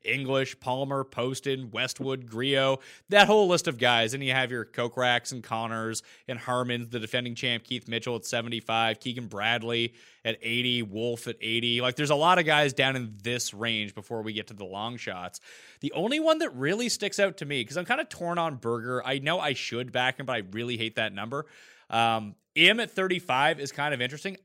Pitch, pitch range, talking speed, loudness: 125 Hz, 115-140 Hz, 215 wpm, -27 LUFS